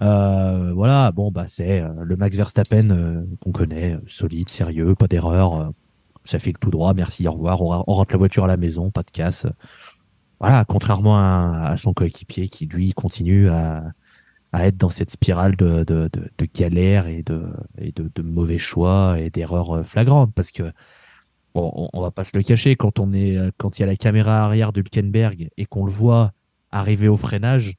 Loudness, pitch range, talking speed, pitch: -19 LUFS, 85-105 Hz, 205 wpm, 95 Hz